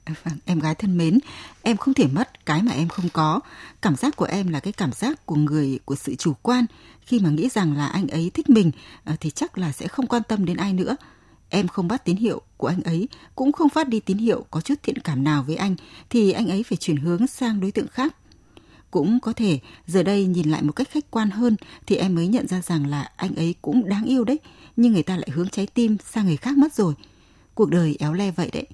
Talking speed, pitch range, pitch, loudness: 250 wpm, 160-230 Hz, 190 Hz, -23 LUFS